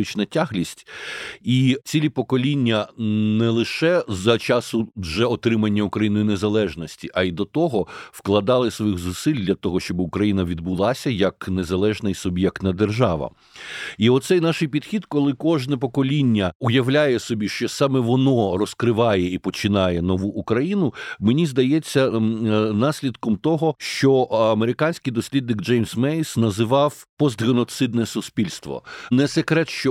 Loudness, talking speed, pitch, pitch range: -21 LUFS, 120 wpm, 115 Hz, 105-135 Hz